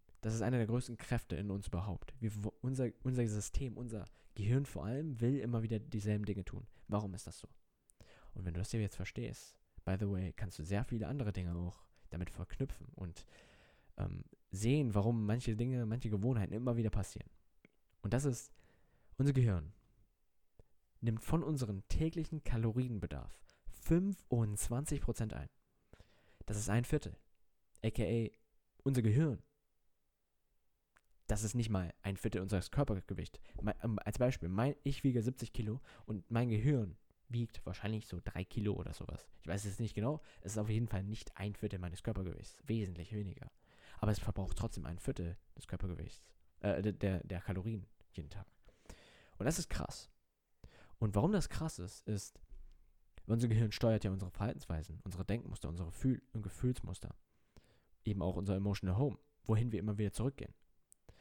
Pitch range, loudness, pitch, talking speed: 95-120 Hz, -39 LUFS, 105 Hz, 160 wpm